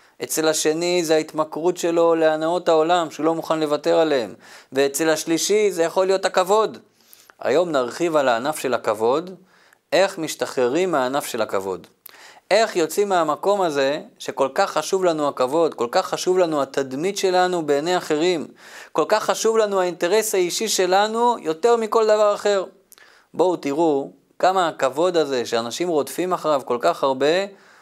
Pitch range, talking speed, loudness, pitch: 155-195 Hz, 145 wpm, -20 LUFS, 170 Hz